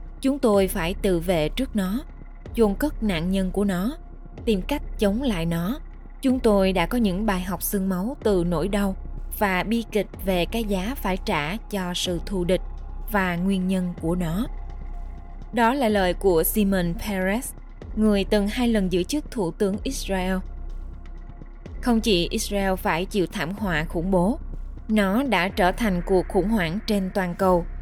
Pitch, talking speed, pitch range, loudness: 195 Hz, 175 wpm, 180-215 Hz, -24 LUFS